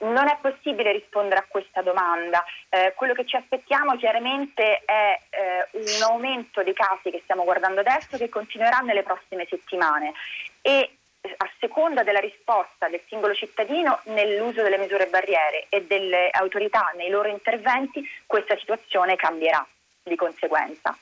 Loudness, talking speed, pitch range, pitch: -23 LUFS, 145 wpm, 185-235 Hz, 205 Hz